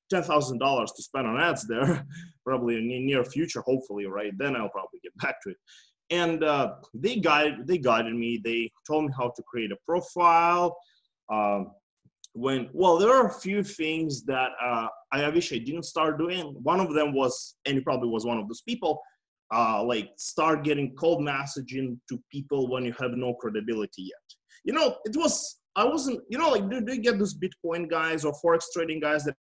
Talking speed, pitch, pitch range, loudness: 200 wpm, 150 Hz, 125-170 Hz, -27 LUFS